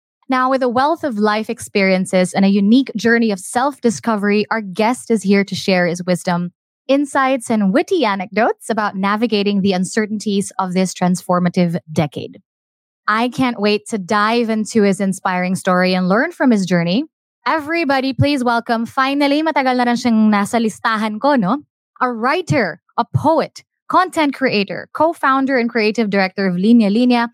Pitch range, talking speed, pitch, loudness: 195-255 Hz, 145 wpm, 220 Hz, -16 LUFS